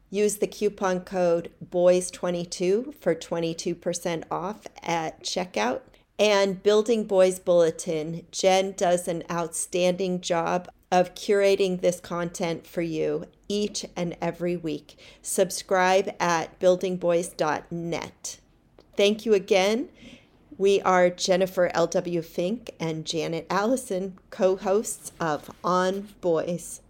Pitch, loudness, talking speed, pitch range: 180 Hz, -25 LUFS, 105 wpm, 170-195 Hz